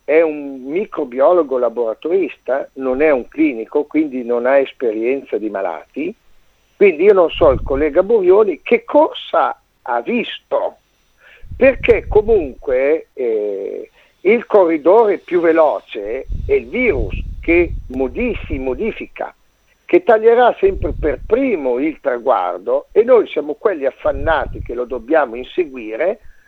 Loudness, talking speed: -16 LUFS, 120 wpm